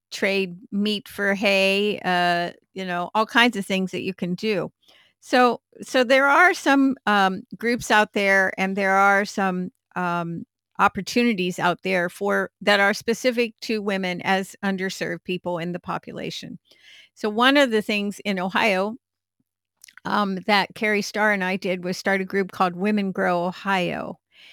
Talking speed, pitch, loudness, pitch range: 160 wpm, 195 Hz, -22 LUFS, 185-215 Hz